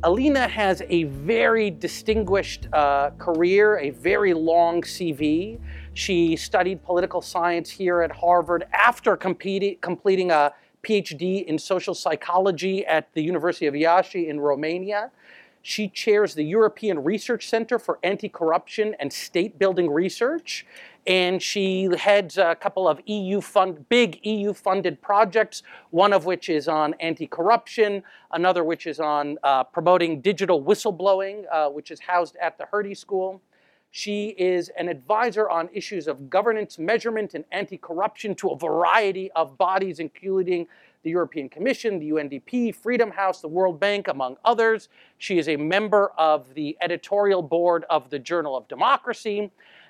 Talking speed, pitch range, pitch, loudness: 145 wpm, 165-205 Hz, 185 Hz, -23 LUFS